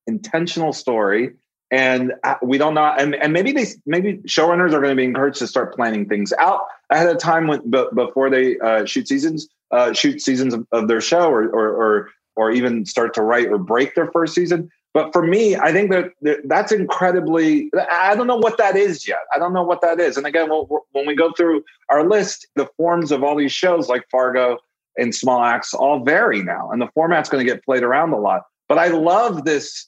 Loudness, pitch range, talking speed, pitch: -18 LUFS, 130-175 Hz, 220 wpm, 155 Hz